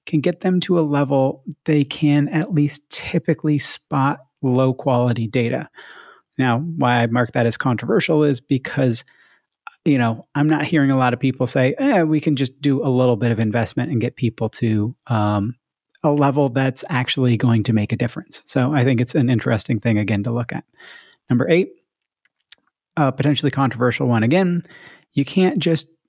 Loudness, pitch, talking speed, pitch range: -19 LUFS, 135 Hz, 180 wpm, 120-155 Hz